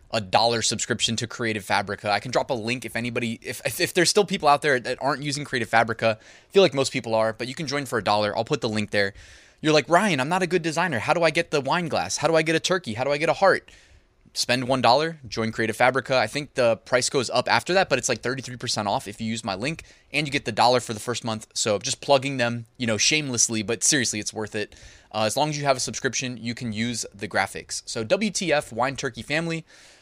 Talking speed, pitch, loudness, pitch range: 265 wpm, 120 Hz, -23 LUFS, 110-145 Hz